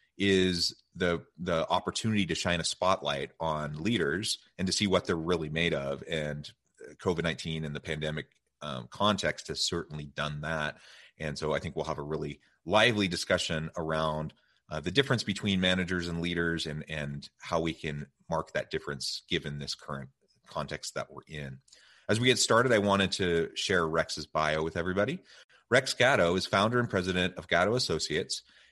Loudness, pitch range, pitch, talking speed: -30 LUFS, 75-95 Hz, 85 Hz, 175 wpm